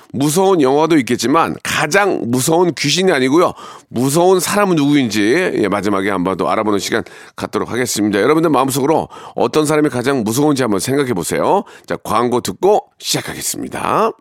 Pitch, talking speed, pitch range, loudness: 135 Hz, 395 characters per minute, 105-155 Hz, -15 LUFS